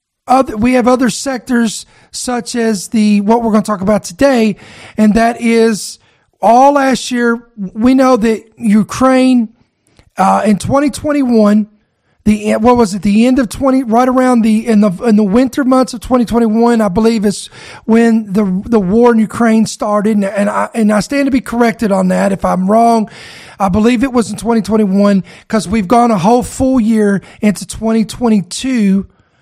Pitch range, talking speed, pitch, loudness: 210-245 Hz, 175 wpm, 225 Hz, -12 LUFS